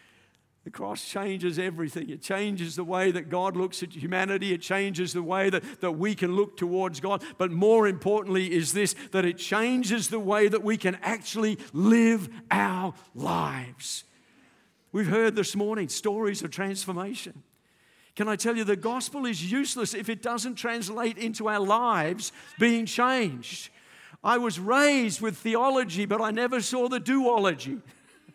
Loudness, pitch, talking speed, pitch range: -27 LUFS, 205 Hz, 160 wpm, 185-230 Hz